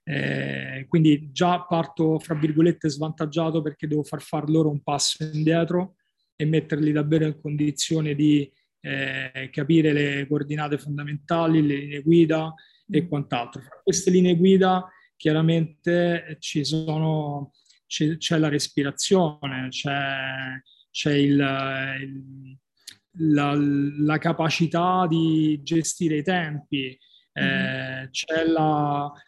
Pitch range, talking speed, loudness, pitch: 140-165 Hz, 115 wpm, -23 LUFS, 150 Hz